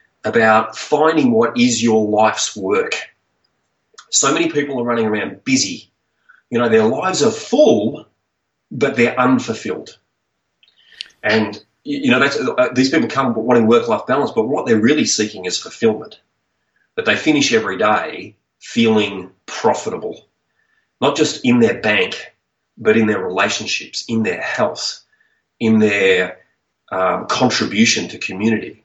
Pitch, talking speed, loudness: 120 Hz, 135 wpm, -16 LUFS